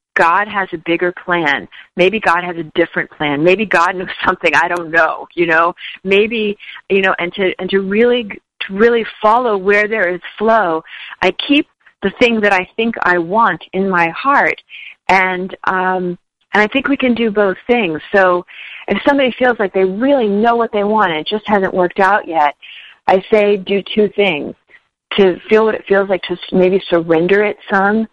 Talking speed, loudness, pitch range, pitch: 195 wpm, -14 LUFS, 180-215 Hz, 195 Hz